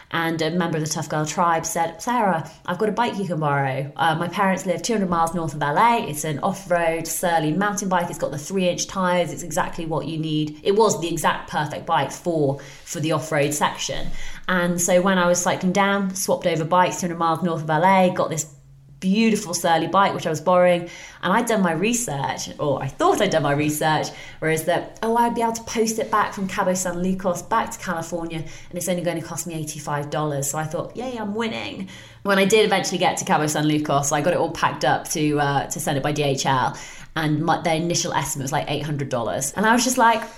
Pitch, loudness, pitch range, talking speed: 170 Hz, -22 LUFS, 155-190 Hz, 240 wpm